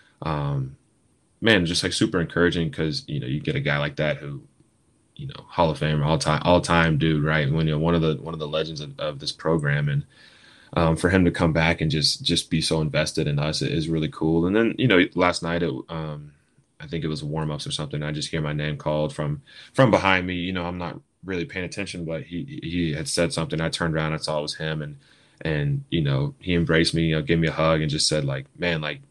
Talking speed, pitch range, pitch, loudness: 260 wpm, 75-85 Hz, 80 Hz, -23 LUFS